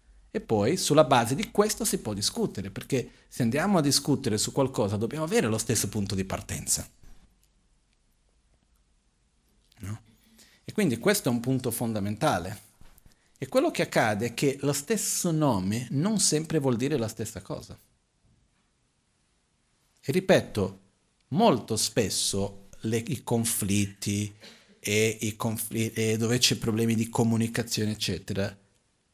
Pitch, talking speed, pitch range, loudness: 115 Hz, 130 wpm, 105-140 Hz, -27 LUFS